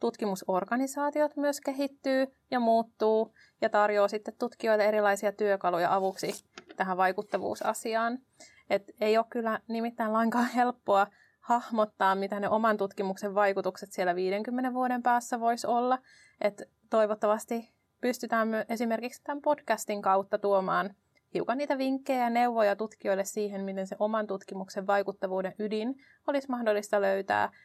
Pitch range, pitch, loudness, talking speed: 200-245 Hz, 220 Hz, -30 LUFS, 125 wpm